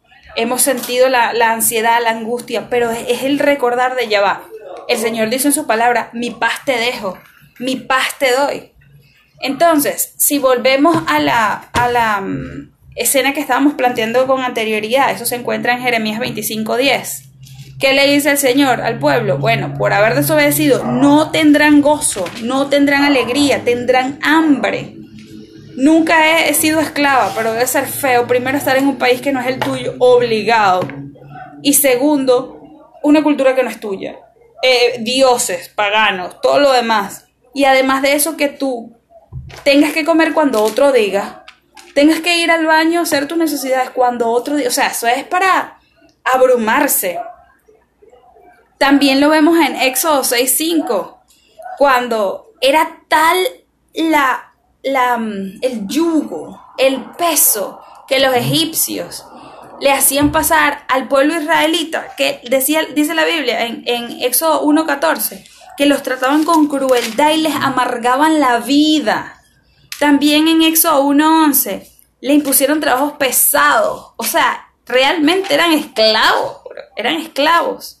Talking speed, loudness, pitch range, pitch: 140 wpm, -13 LUFS, 245-305 Hz, 270 Hz